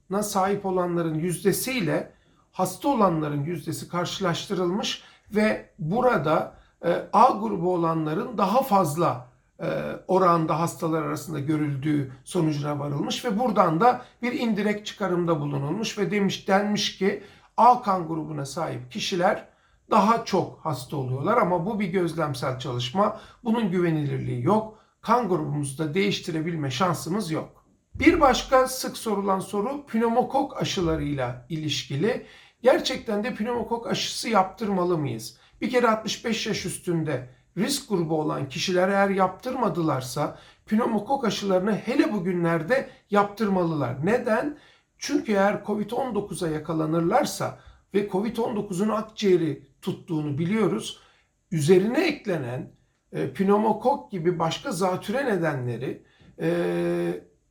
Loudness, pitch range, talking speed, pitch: -25 LUFS, 160-215 Hz, 105 wpm, 190 Hz